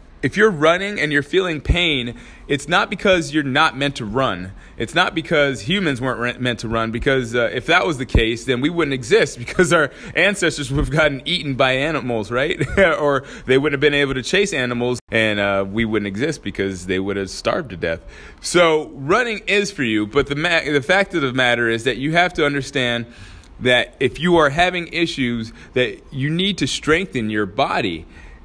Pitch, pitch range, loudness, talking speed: 140 Hz, 120-165 Hz, -18 LUFS, 205 wpm